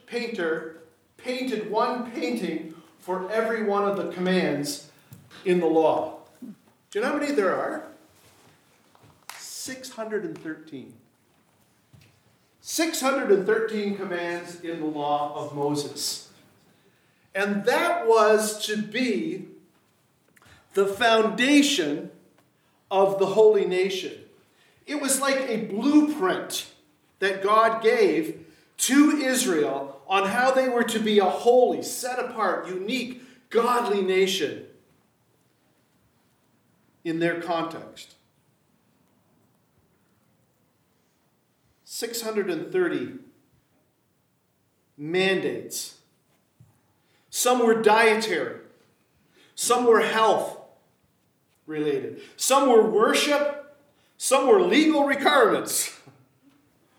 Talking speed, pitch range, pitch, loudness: 85 wpm, 180-270 Hz, 220 Hz, -23 LUFS